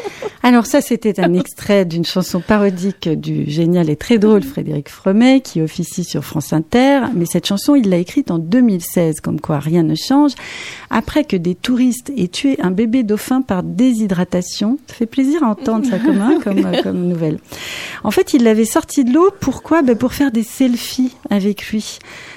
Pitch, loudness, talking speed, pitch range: 215 Hz, -15 LUFS, 190 wpm, 180-260 Hz